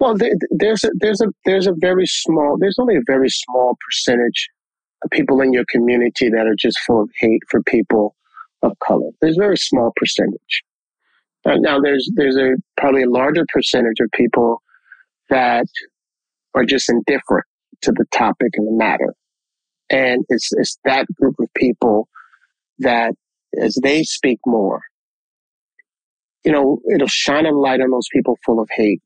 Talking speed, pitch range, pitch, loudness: 165 wpm, 120-195 Hz, 135 Hz, -16 LUFS